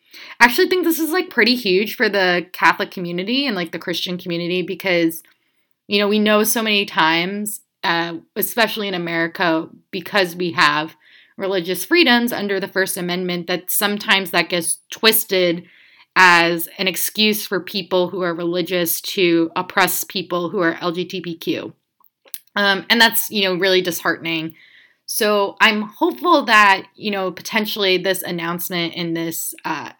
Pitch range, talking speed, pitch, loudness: 175-210 Hz, 150 wpm, 185 Hz, -18 LUFS